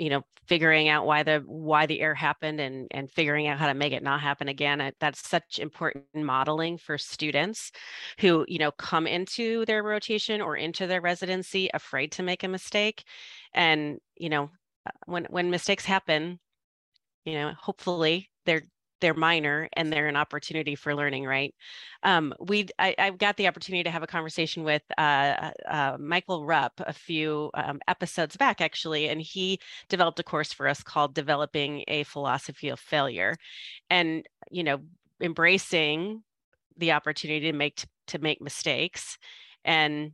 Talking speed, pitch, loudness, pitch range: 165 wpm, 160 Hz, -27 LUFS, 150-180 Hz